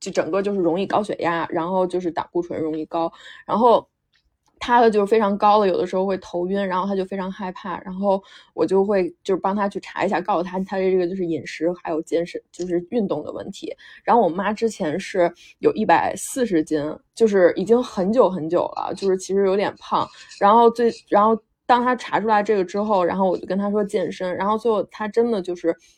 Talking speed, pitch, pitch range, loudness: 325 characters per minute, 190 Hz, 175-210 Hz, -21 LUFS